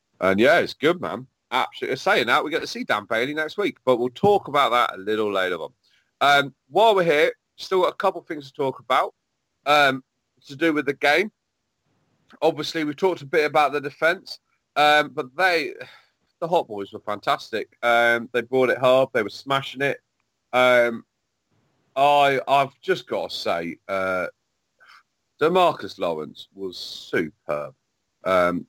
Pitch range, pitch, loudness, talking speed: 120-155 Hz, 140 Hz, -22 LUFS, 170 wpm